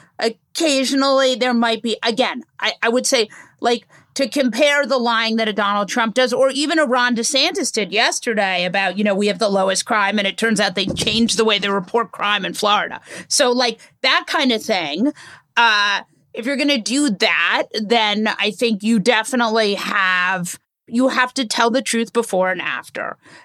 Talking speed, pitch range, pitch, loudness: 190 wpm, 205-255 Hz, 230 Hz, -17 LUFS